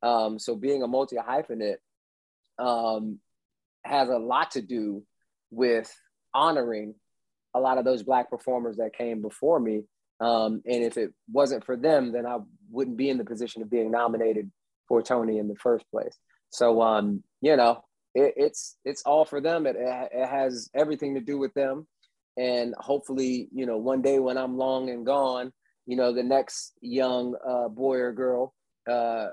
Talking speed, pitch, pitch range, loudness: 175 wpm, 125 Hz, 115-130 Hz, -27 LUFS